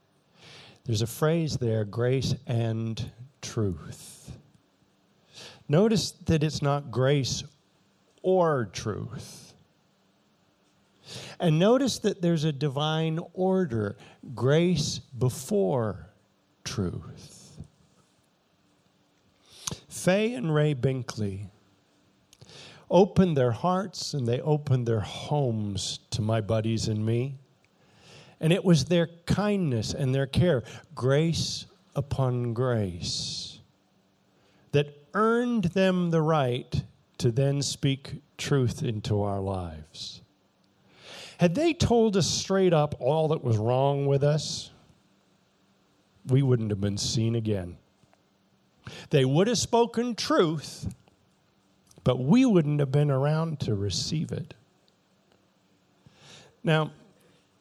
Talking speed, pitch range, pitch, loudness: 100 wpm, 115-165 Hz, 140 Hz, -27 LUFS